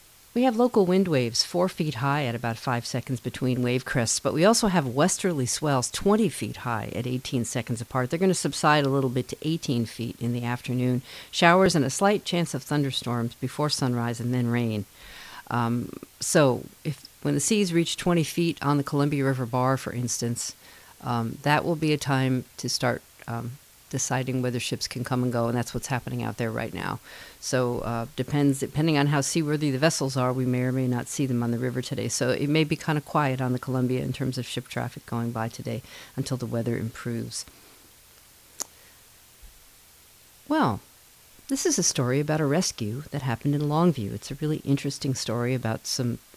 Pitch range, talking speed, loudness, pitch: 120-150 Hz, 200 wpm, -26 LUFS, 130 Hz